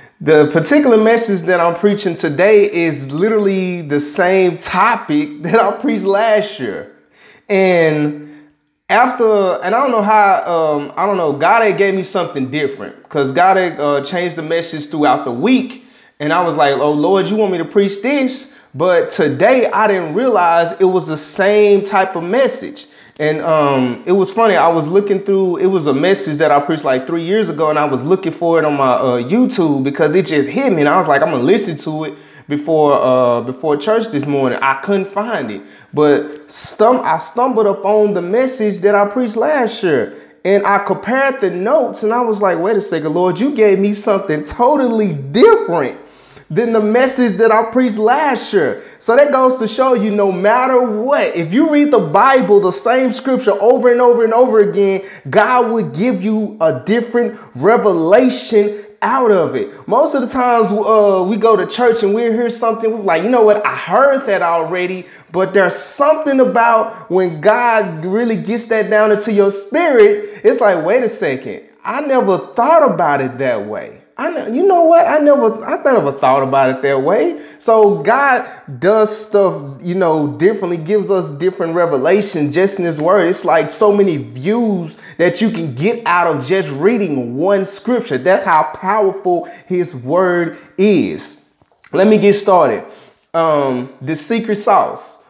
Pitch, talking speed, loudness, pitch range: 195 Hz, 190 wpm, -14 LUFS, 165-225 Hz